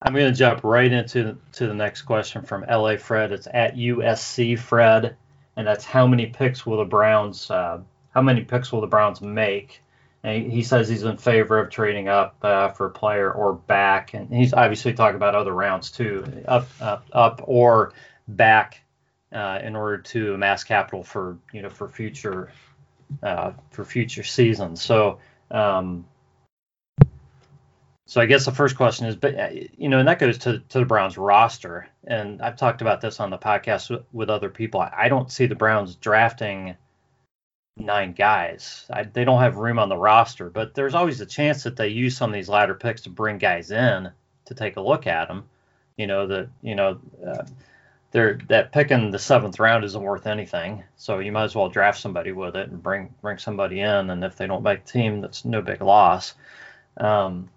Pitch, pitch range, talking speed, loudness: 110 Hz, 105-125 Hz, 195 wpm, -21 LUFS